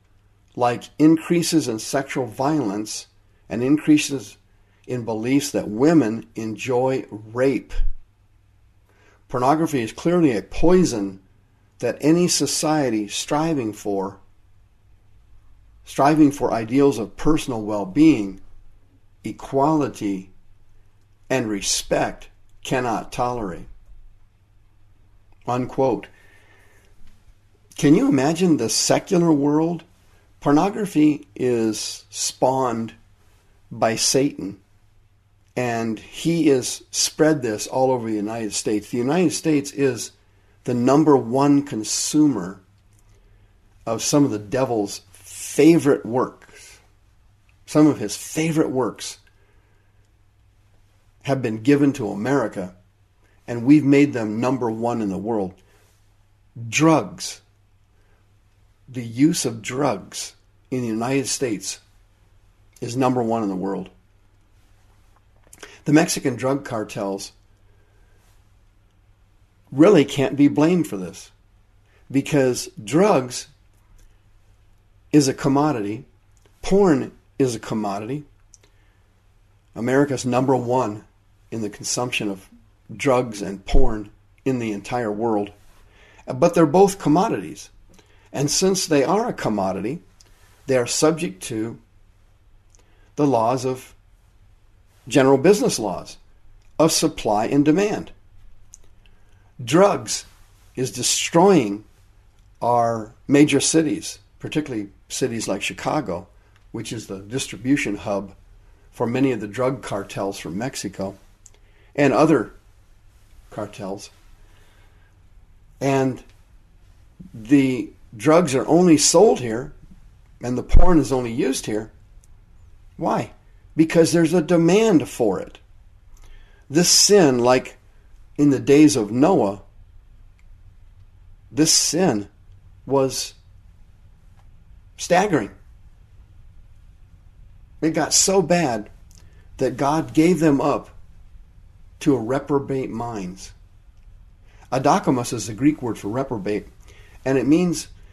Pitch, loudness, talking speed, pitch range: 105 Hz, -20 LUFS, 100 wpm, 100-135 Hz